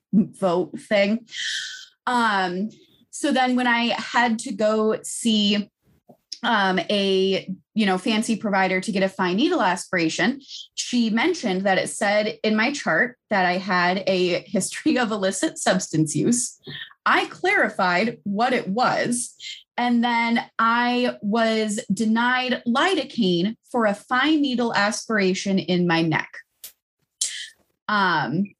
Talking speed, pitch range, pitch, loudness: 125 wpm, 190-245 Hz, 215 Hz, -22 LUFS